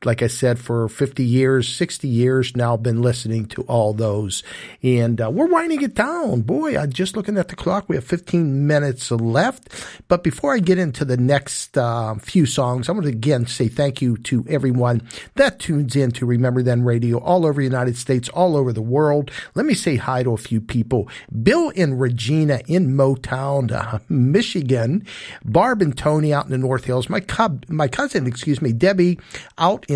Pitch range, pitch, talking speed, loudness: 120-170 Hz, 135 Hz, 200 wpm, -19 LUFS